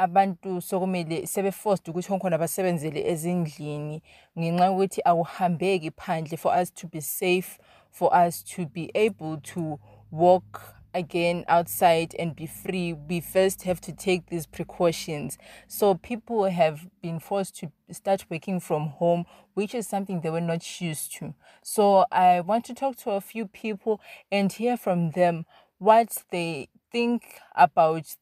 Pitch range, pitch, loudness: 165-195 Hz, 180 Hz, -26 LUFS